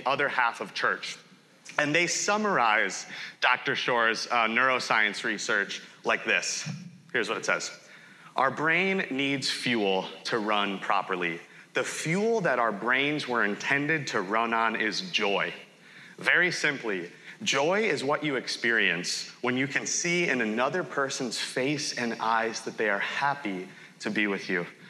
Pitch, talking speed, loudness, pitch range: 130 Hz, 150 wpm, -27 LUFS, 110-160 Hz